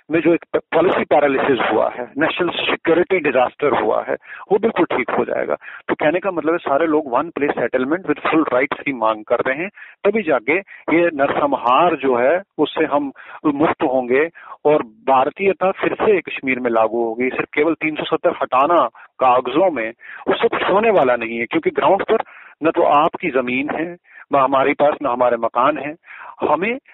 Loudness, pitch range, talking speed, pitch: -18 LUFS, 130-170 Hz, 180 wpm, 150 Hz